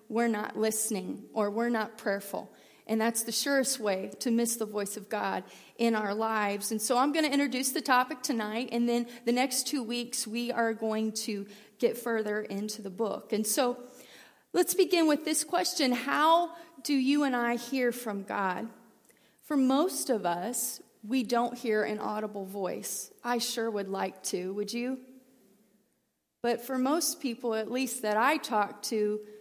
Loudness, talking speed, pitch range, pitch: -30 LUFS, 180 wpm, 215-255 Hz, 235 Hz